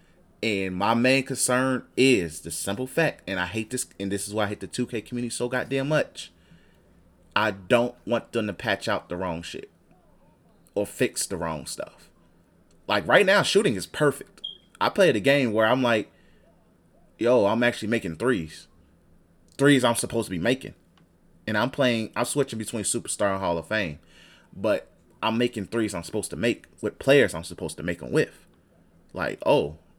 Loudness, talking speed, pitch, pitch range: -25 LUFS, 185 wpm, 110 Hz, 85-125 Hz